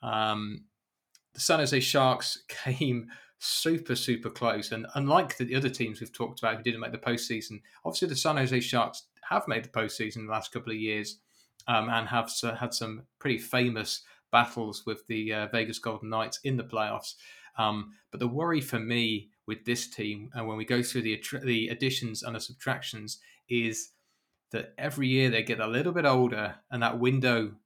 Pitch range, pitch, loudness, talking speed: 110-125 Hz, 115 Hz, -30 LUFS, 190 wpm